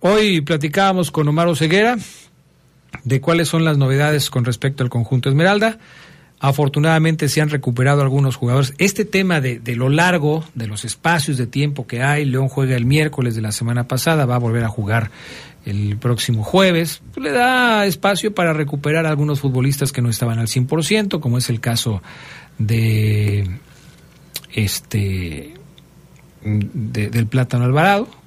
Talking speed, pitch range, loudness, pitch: 155 wpm, 120-165 Hz, -17 LUFS, 140 Hz